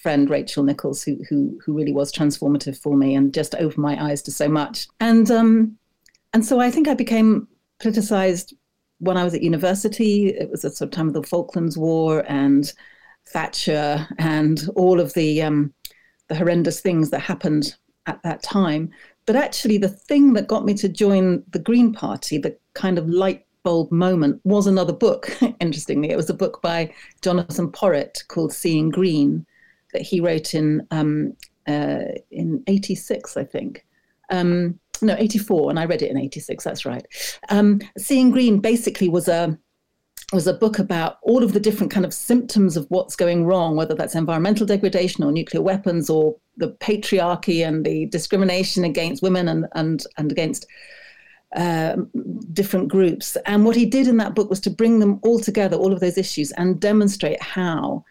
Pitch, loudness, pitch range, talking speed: 180 Hz, -20 LUFS, 160-205 Hz, 180 wpm